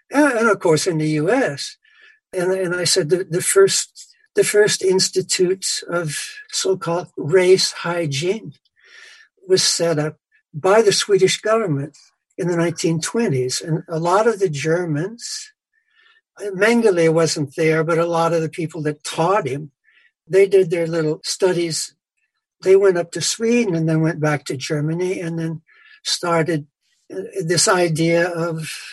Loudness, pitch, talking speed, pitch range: -18 LUFS, 180 Hz, 145 wpm, 165-230 Hz